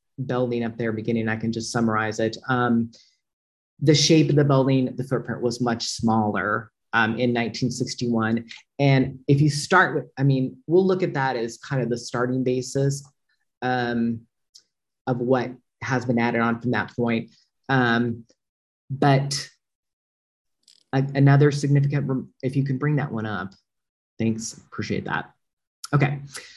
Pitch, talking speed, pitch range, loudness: 125 Hz, 150 wpm, 115-135 Hz, -23 LUFS